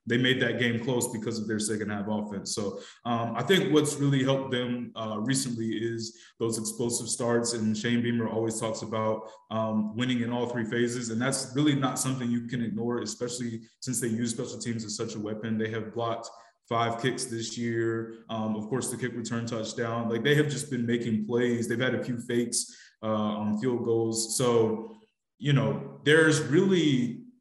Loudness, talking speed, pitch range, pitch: -29 LUFS, 195 wpm, 115-125 Hz, 120 Hz